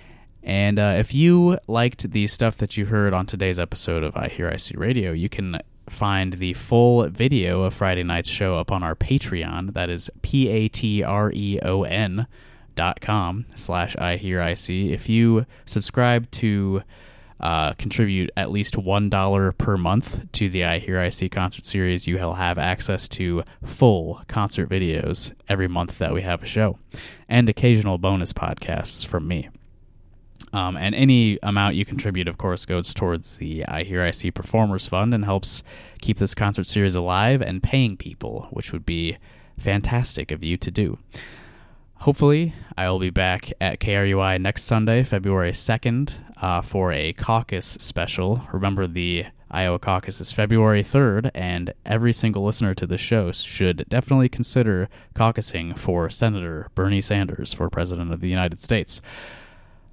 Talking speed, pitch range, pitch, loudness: 165 wpm, 90-110 Hz, 100 Hz, -22 LUFS